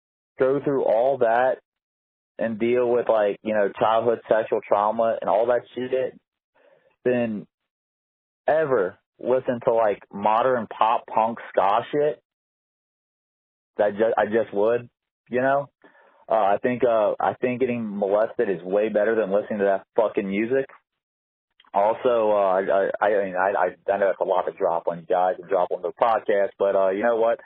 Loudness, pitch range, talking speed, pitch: -23 LUFS, 100-125 Hz, 175 wpm, 110 Hz